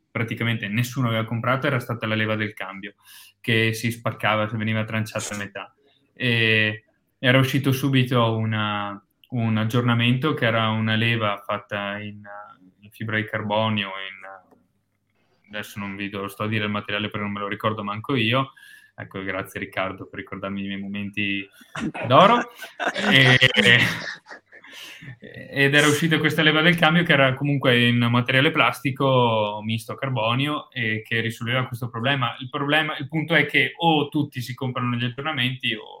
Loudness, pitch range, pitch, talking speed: -21 LUFS, 105-130 Hz, 115 Hz, 160 wpm